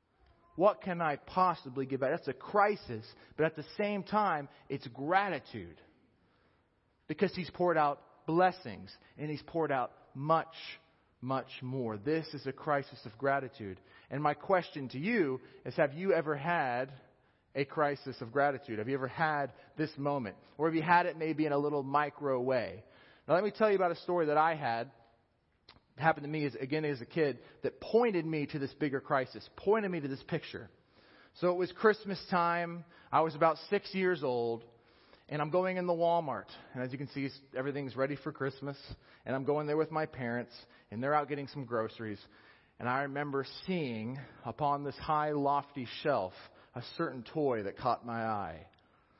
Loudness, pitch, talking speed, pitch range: -34 LUFS, 145 Hz, 185 wpm, 130-165 Hz